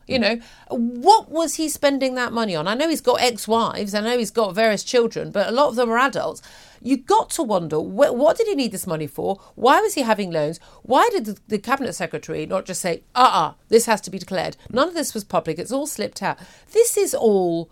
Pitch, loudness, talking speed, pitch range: 230 Hz, -21 LUFS, 245 wpm, 195-280 Hz